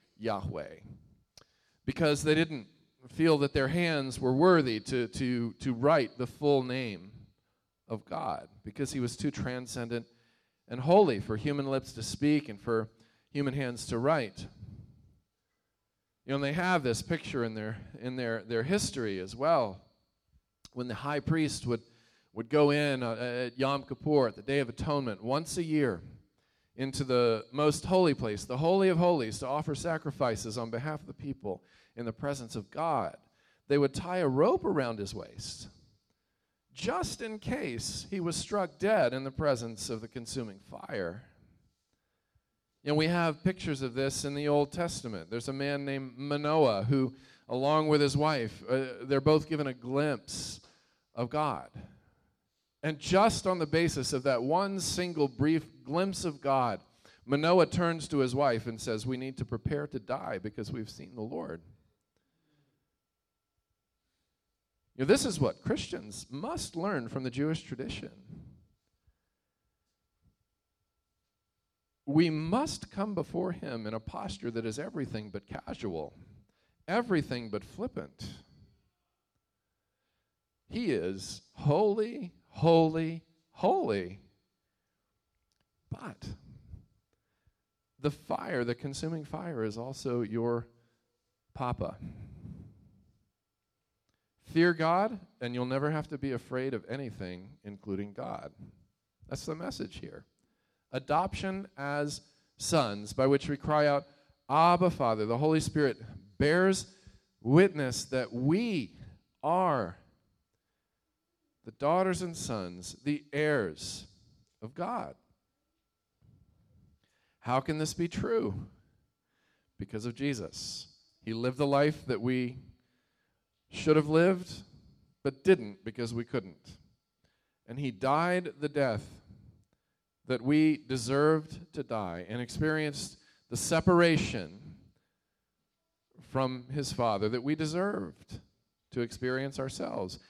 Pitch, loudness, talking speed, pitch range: 135 Hz, -31 LUFS, 130 wpm, 115-150 Hz